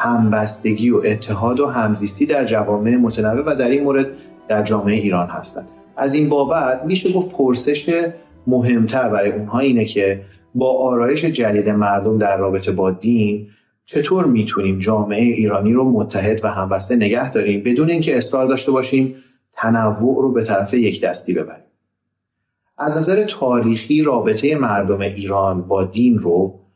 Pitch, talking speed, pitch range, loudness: 115 Hz, 150 wpm, 105-135 Hz, -17 LUFS